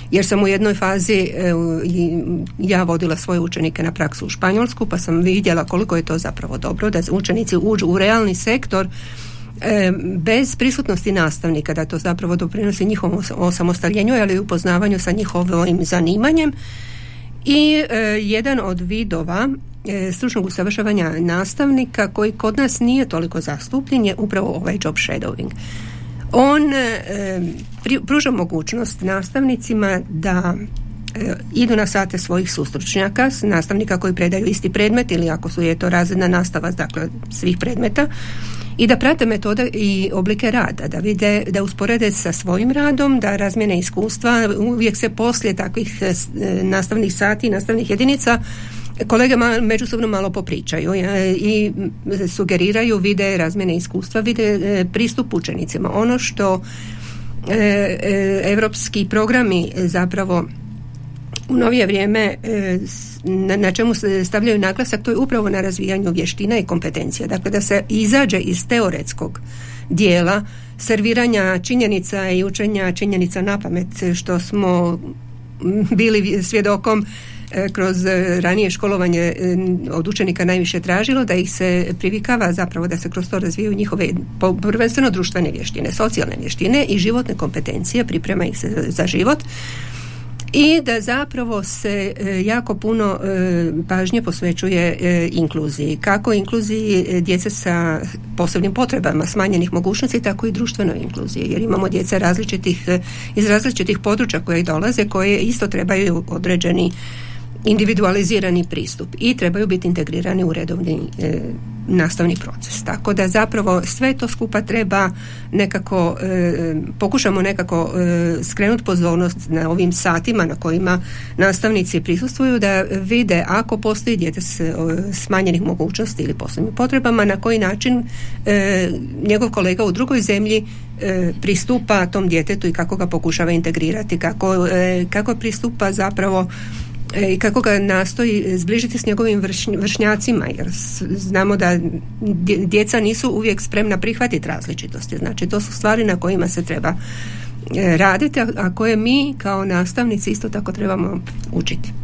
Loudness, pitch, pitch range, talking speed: -18 LUFS, 190 Hz, 170-215 Hz, 135 wpm